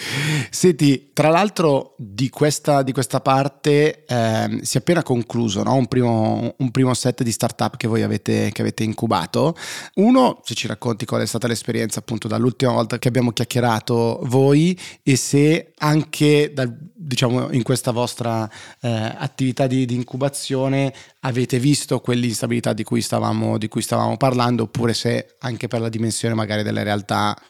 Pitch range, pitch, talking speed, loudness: 115-135 Hz, 125 Hz, 160 wpm, -20 LUFS